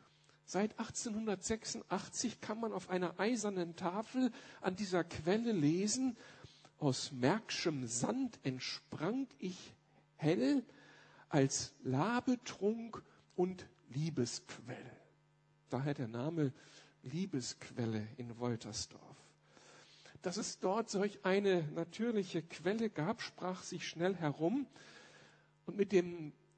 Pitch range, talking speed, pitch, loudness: 145-210 Hz, 95 wpm, 180 Hz, -38 LUFS